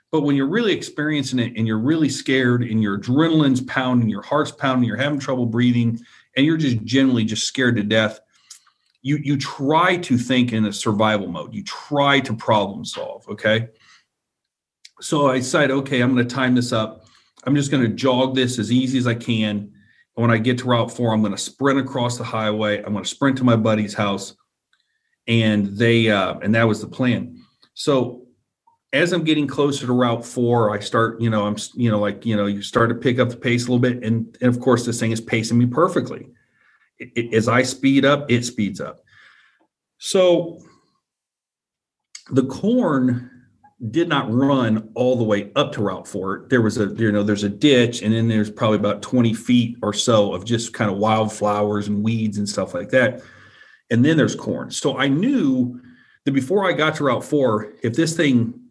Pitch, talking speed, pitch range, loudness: 120 Hz, 205 wpm, 110-135 Hz, -20 LUFS